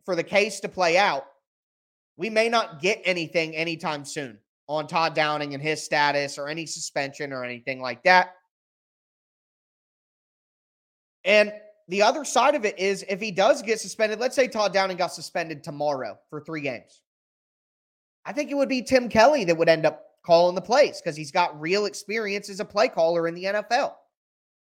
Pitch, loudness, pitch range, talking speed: 180 Hz, -24 LUFS, 155-210 Hz, 180 wpm